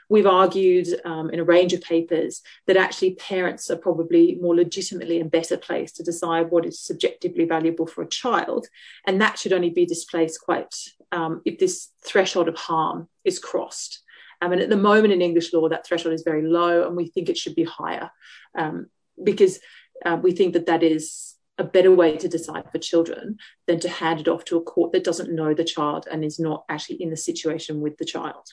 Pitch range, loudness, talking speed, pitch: 165-195 Hz, -22 LUFS, 210 wpm, 175 Hz